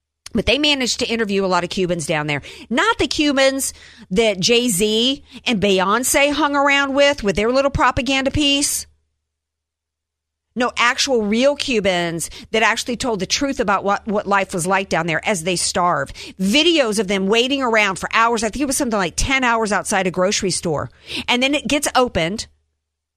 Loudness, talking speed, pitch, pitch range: -17 LUFS, 180 wpm, 220 Hz, 185-265 Hz